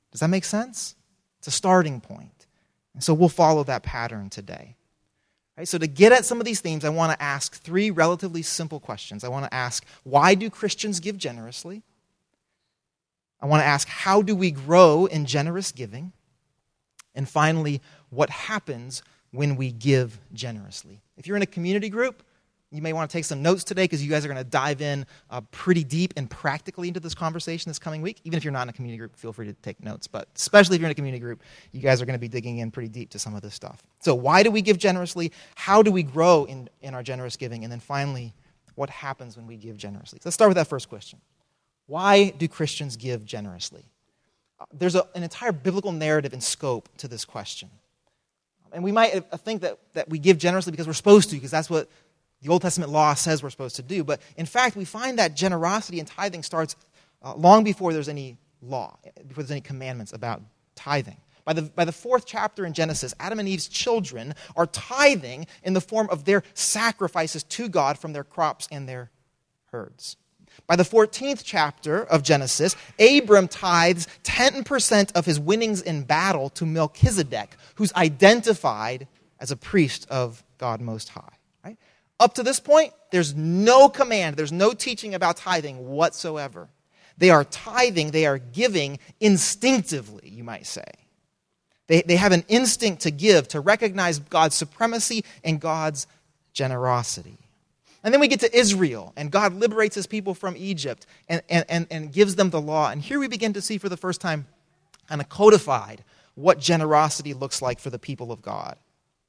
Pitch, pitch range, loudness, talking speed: 160 Hz, 140-190 Hz, -22 LUFS, 195 wpm